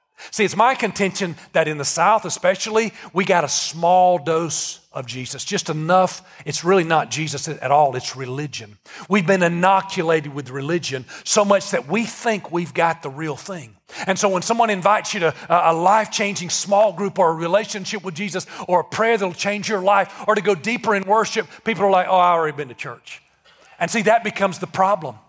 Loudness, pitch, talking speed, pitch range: -19 LUFS, 185 Hz, 200 wpm, 160-205 Hz